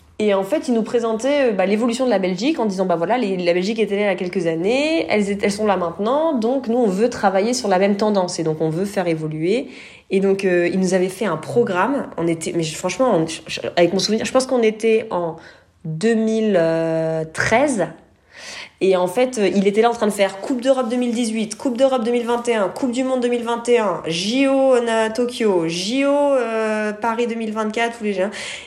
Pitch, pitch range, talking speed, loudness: 215 Hz, 185-240 Hz, 210 wpm, -19 LUFS